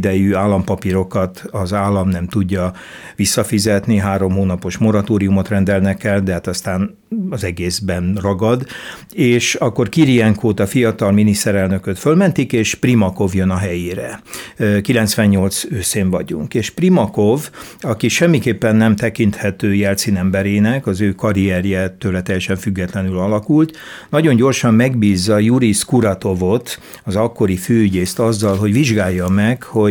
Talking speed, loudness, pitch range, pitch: 120 wpm, -16 LUFS, 95-115 Hz, 100 Hz